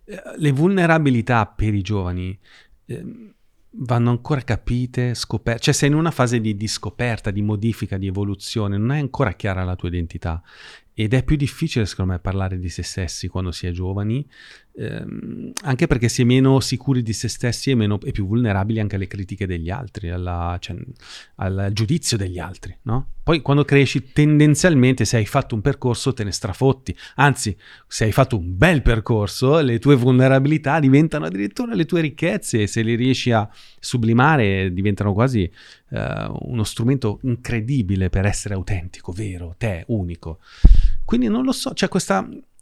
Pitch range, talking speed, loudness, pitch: 100-135 Hz, 170 wpm, -20 LUFS, 115 Hz